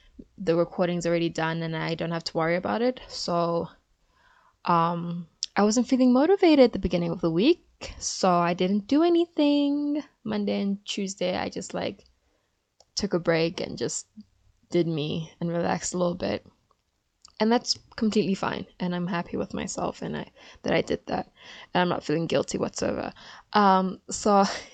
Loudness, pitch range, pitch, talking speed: -26 LUFS, 170-235 Hz, 185 Hz, 170 wpm